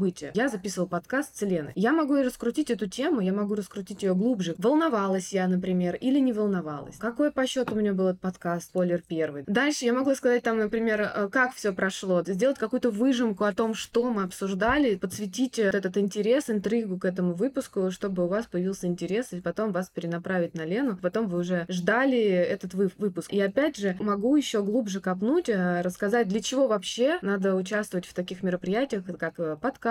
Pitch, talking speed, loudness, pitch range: 205 Hz, 185 wpm, -27 LUFS, 185-240 Hz